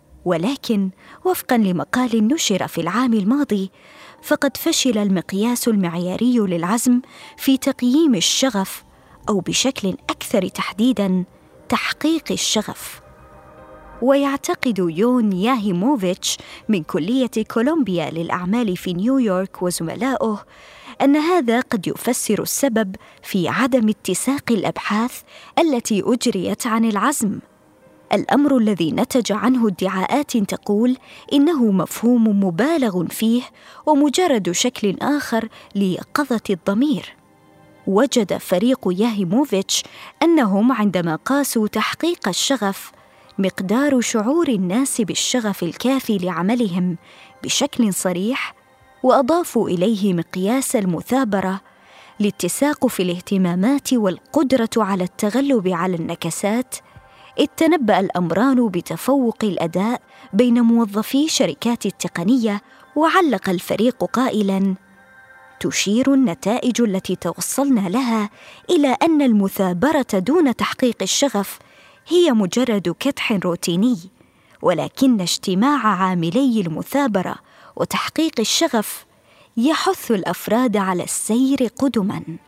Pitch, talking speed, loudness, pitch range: 225 Hz, 90 wpm, -19 LUFS, 190-265 Hz